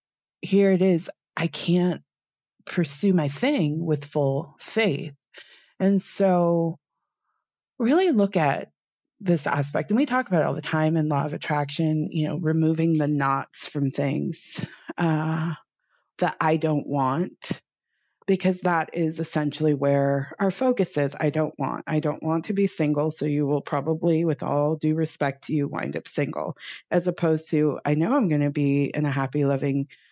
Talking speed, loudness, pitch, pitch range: 165 wpm, -24 LUFS, 155 Hz, 145-175 Hz